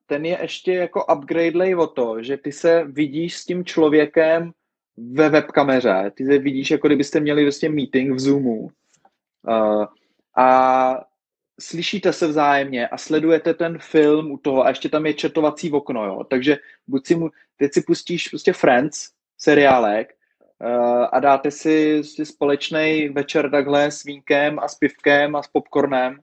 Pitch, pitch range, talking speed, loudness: 150 Hz, 140-160 Hz, 160 wpm, -19 LUFS